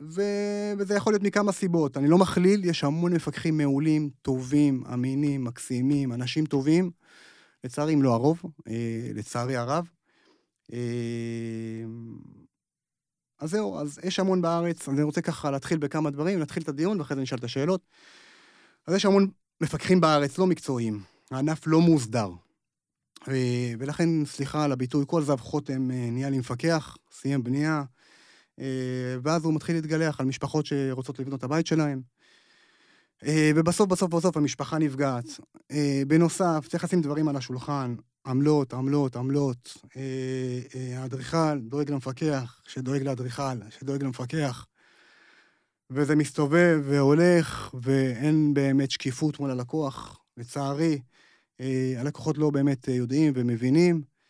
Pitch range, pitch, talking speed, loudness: 130-160 Hz, 145 Hz, 125 wpm, -26 LUFS